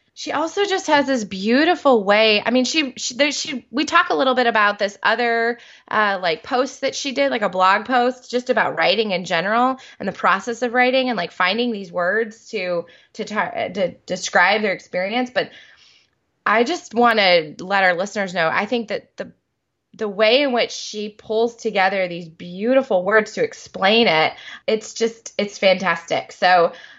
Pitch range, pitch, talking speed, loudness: 195-255 Hz, 230 Hz, 185 wpm, -19 LUFS